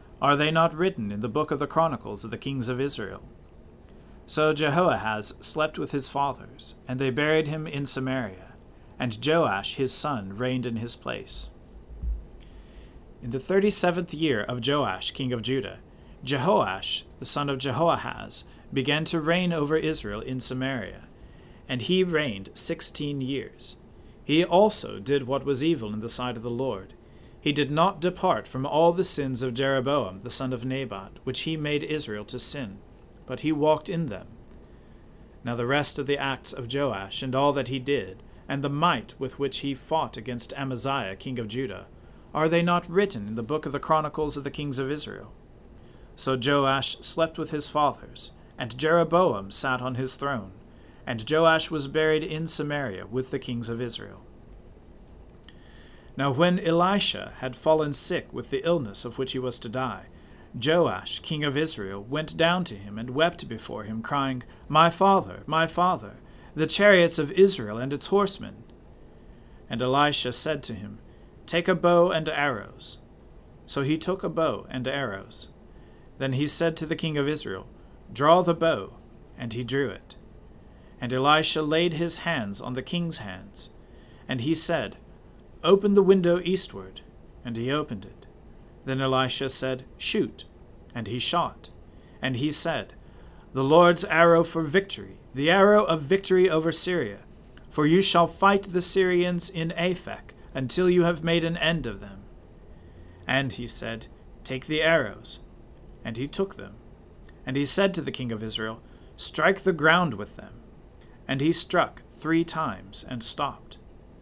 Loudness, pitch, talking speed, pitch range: -25 LUFS, 140 Hz, 170 wpm, 120-165 Hz